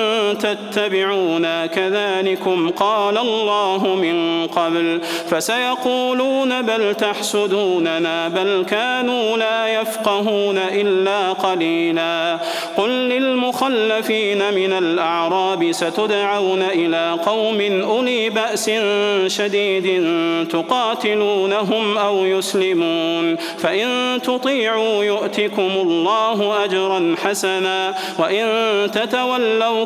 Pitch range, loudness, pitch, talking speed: 180-220 Hz, -18 LUFS, 200 Hz, 70 wpm